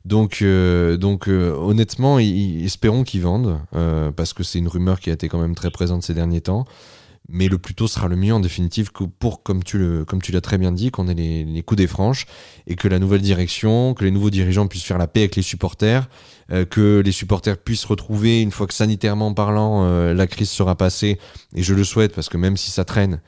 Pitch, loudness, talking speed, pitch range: 95 Hz, -19 LUFS, 245 wpm, 90-105 Hz